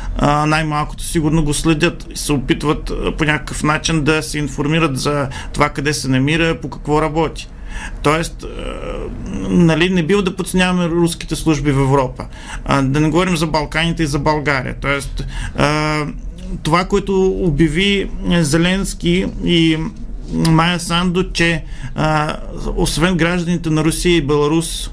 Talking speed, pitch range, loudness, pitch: 130 wpm, 150-170 Hz, -16 LUFS, 160 Hz